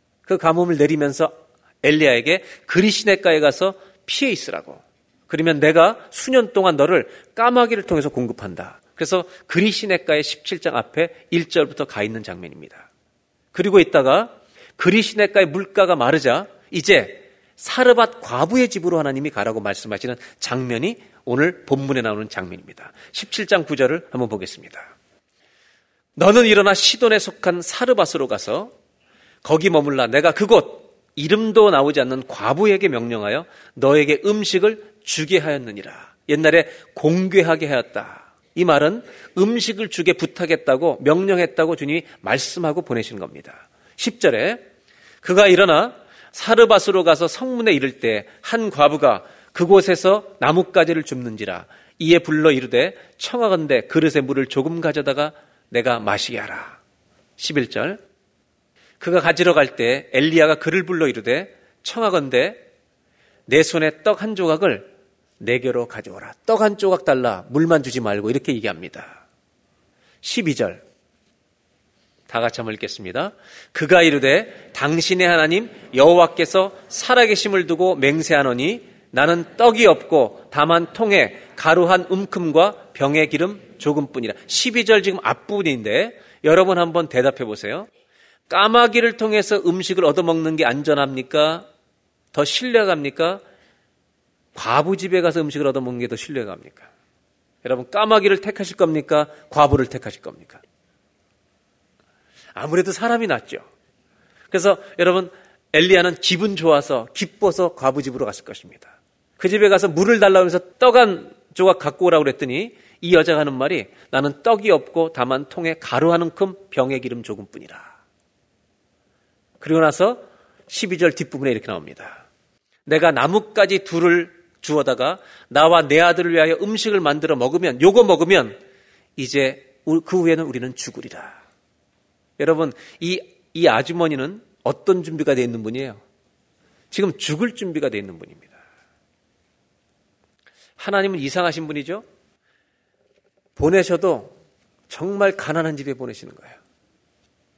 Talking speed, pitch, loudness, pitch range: 300 characters per minute, 165 Hz, -18 LUFS, 145-195 Hz